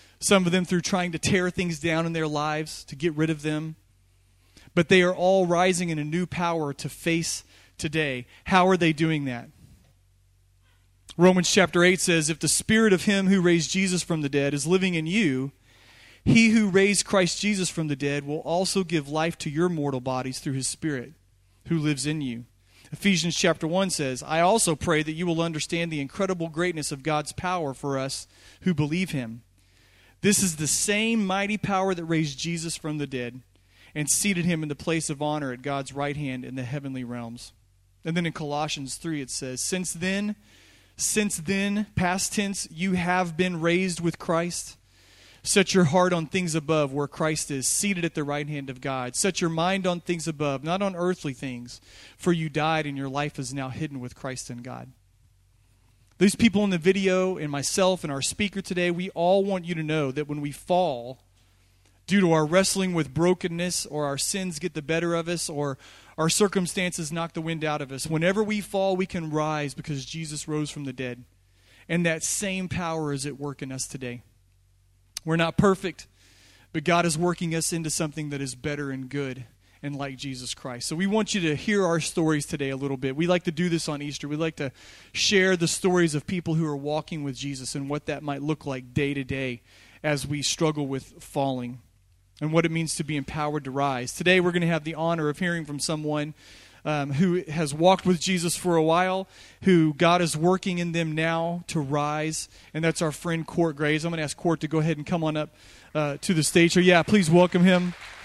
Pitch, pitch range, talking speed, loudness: 155 Hz, 135-175 Hz, 210 wpm, -25 LUFS